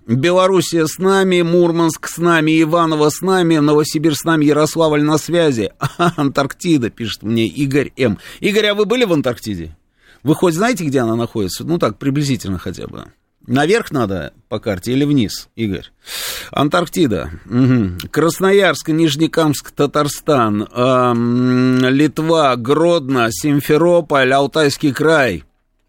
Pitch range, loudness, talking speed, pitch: 125-165 Hz, -15 LUFS, 125 wpm, 150 Hz